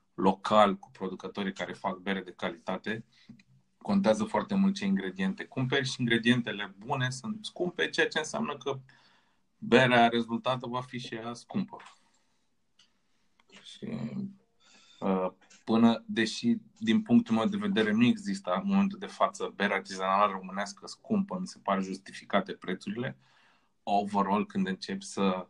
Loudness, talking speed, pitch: -30 LUFS, 135 wpm, 125 Hz